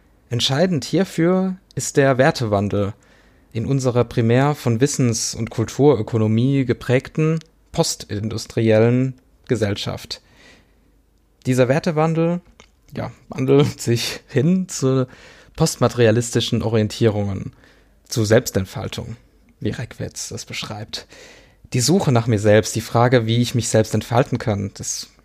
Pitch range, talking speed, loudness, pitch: 110-140 Hz, 105 wpm, -19 LUFS, 120 Hz